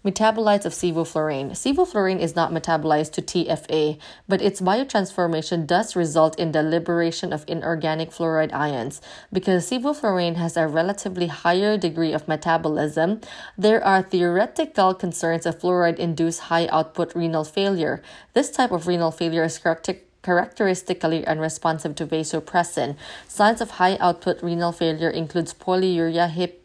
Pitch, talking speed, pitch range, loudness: 170 Hz, 135 wpm, 160-185 Hz, -22 LUFS